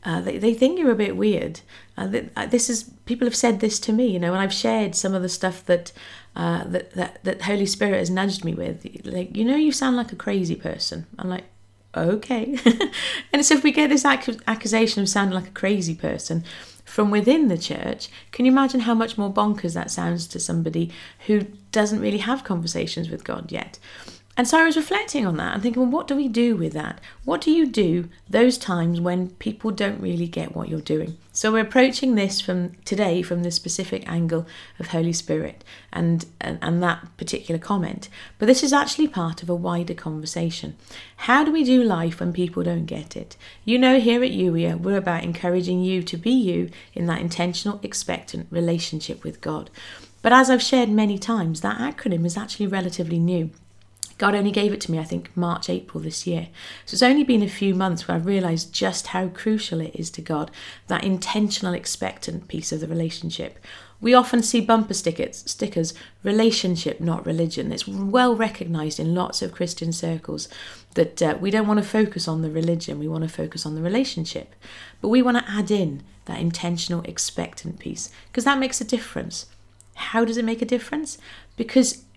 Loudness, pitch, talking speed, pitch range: -22 LUFS, 190 Hz, 200 wpm, 170-230 Hz